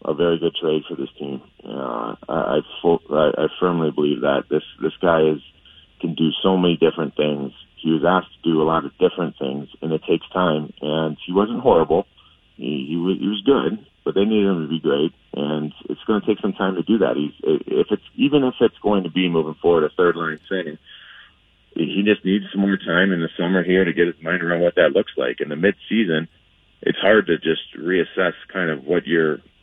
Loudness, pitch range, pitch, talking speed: -20 LUFS, 80-95 Hz, 85 Hz, 230 wpm